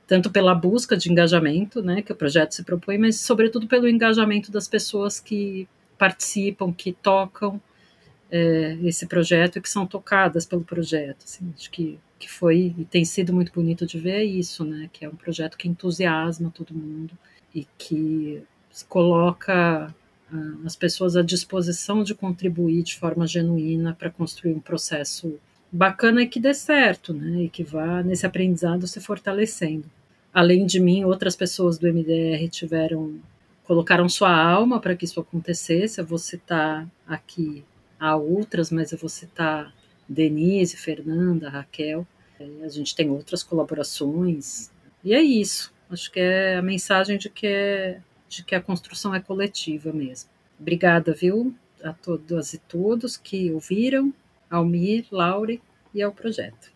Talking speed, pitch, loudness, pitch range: 155 wpm, 175 Hz, -22 LUFS, 165-195 Hz